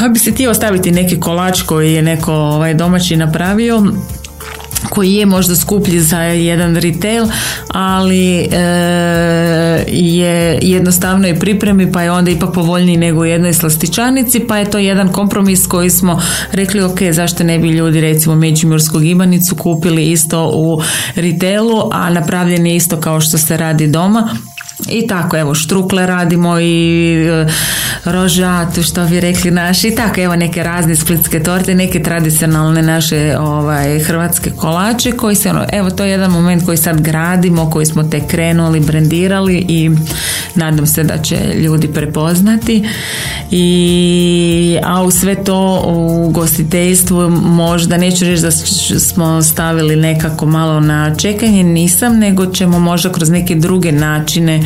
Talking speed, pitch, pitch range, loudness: 150 wpm, 175 Hz, 160-185 Hz, -11 LUFS